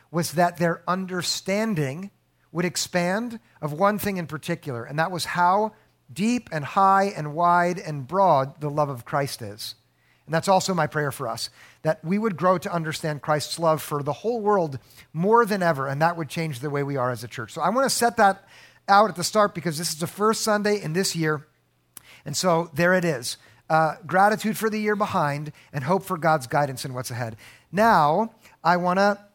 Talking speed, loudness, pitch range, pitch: 210 wpm, -23 LUFS, 145-195 Hz, 170 Hz